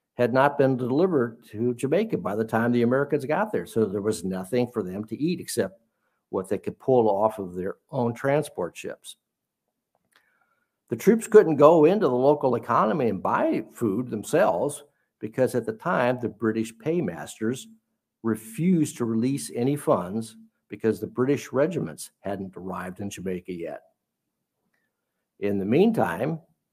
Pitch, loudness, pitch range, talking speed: 120 Hz, -25 LUFS, 105-135 Hz, 155 wpm